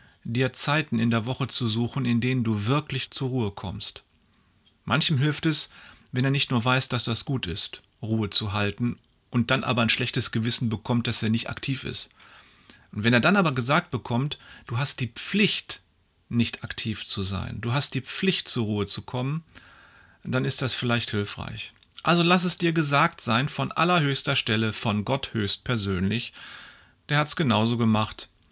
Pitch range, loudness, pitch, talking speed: 110-140 Hz, -24 LUFS, 120 Hz, 185 wpm